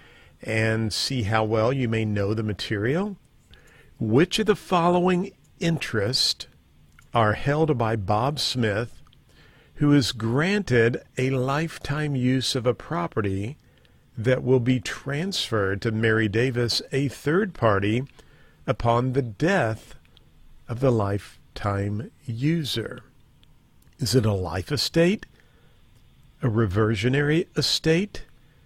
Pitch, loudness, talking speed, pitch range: 125 Hz, -24 LUFS, 110 wpm, 110-145 Hz